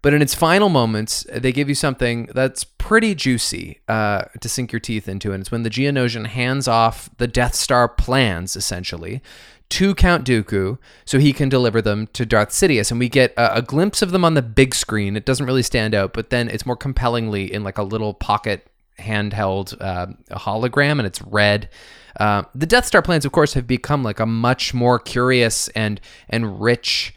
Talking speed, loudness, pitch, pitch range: 200 wpm, -19 LUFS, 120 Hz, 105-130 Hz